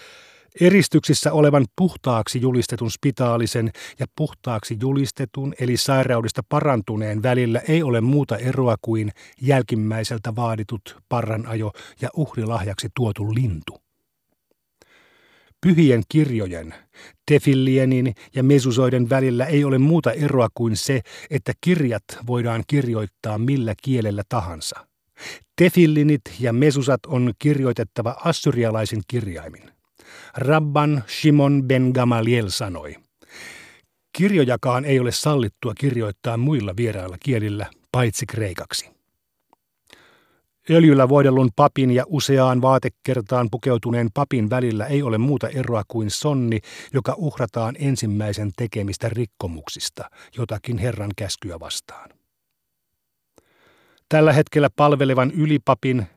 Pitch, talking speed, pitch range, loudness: 125 Hz, 100 wpm, 115-140 Hz, -20 LUFS